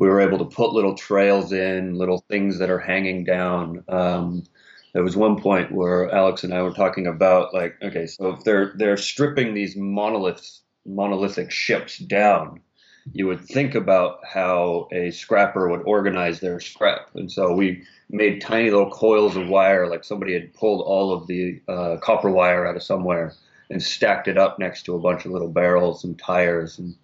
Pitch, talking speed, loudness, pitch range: 95 Hz, 190 wpm, -21 LUFS, 90-100 Hz